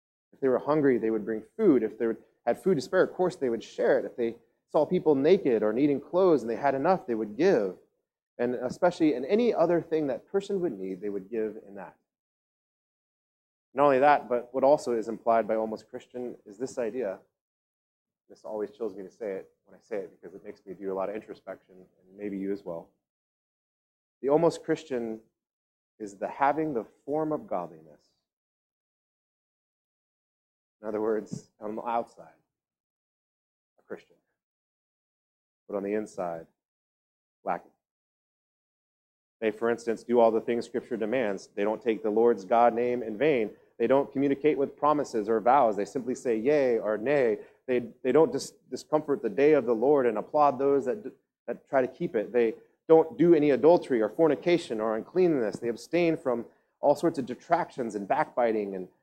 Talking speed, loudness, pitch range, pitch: 185 wpm, -27 LUFS, 110-150 Hz, 125 Hz